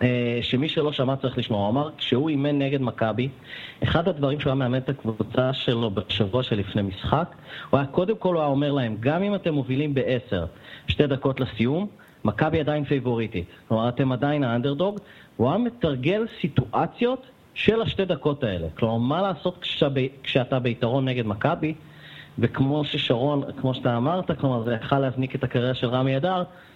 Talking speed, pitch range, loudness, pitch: 170 wpm, 125-150 Hz, -25 LUFS, 135 Hz